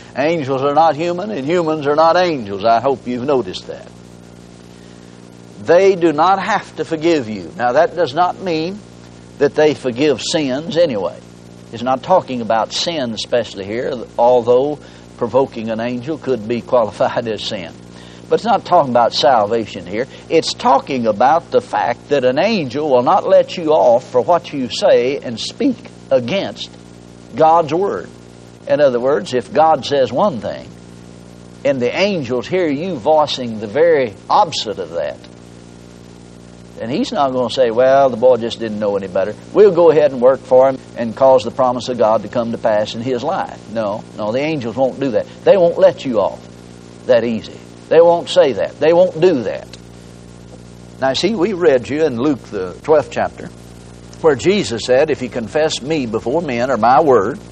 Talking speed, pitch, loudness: 180 wpm, 120 Hz, -15 LUFS